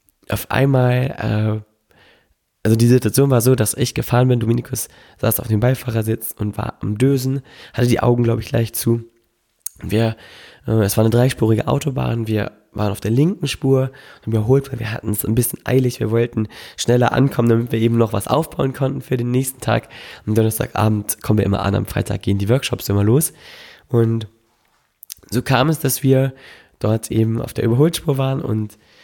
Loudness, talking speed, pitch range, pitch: -18 LUFS, 180 wpm, 110-130 Hz, 115 Hz